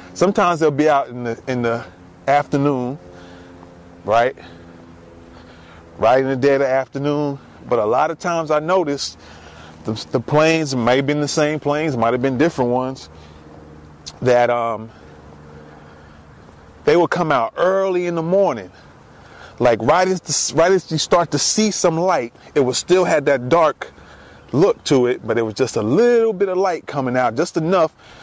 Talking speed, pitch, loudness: 175 wpm, 130 Hz, -18 LUFS